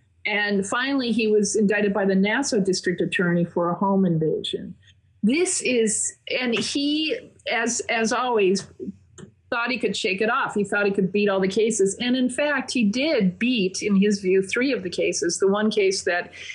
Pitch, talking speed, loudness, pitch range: 210 Hz, 190 wpm, -22 LUFS, 195-240 Hz